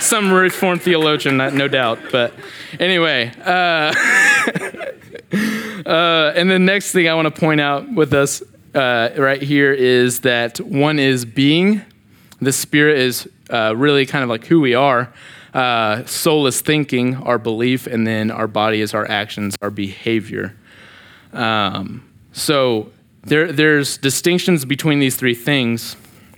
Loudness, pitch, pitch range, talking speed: -16 LUFS, 140 Hz, 120-160 Hz, 145 wpm